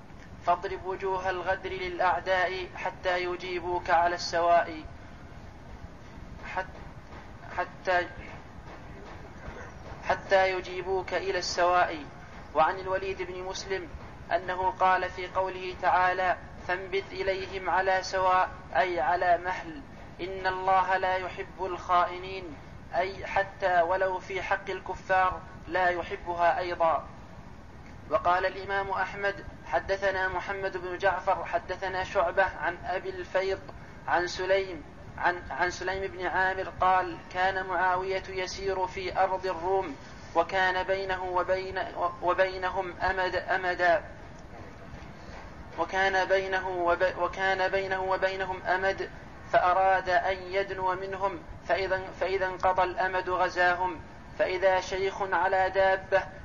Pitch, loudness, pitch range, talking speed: 185 Hz, -29 LUFS, 180-190 Hz, 100 wpm